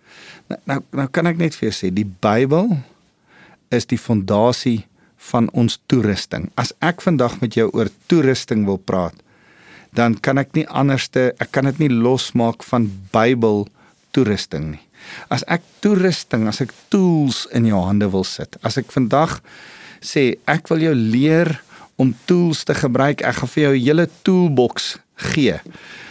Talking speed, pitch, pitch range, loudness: 165 wpm, 125 Hz, 110-150 Hz, -18 LUFS